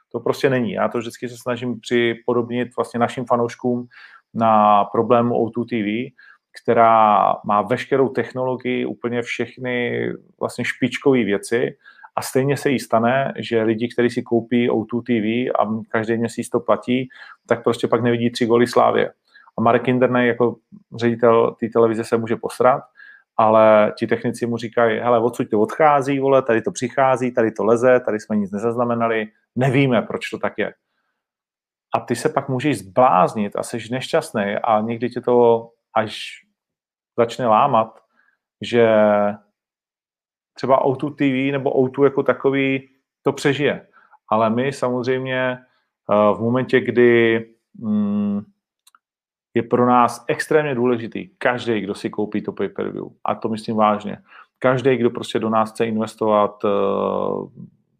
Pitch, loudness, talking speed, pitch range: 120 Hz, -19 LUFS, 145 wpm, 115-130 Hz